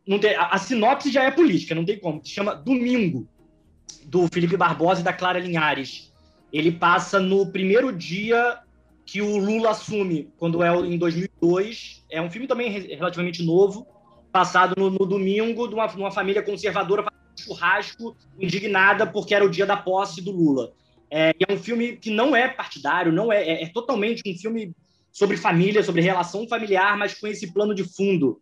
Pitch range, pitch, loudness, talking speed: 175-210 Hz, 195 Hz, -22 LUFS, 190 wpm